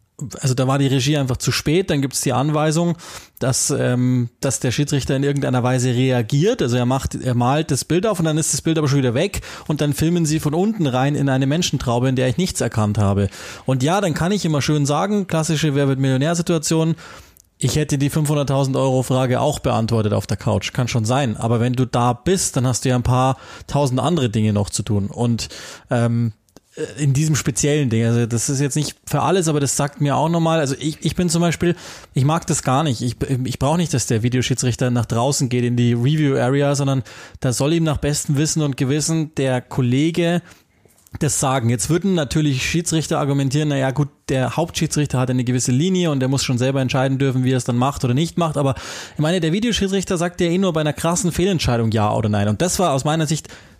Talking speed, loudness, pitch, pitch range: 225 wpm, -19 LUFS, 140 Hz, 125-155 Hz